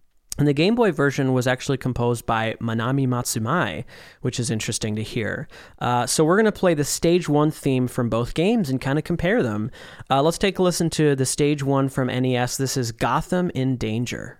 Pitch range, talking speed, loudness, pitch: 120-155 Hz, 210 wpm, -22 LUFS, 130 Hz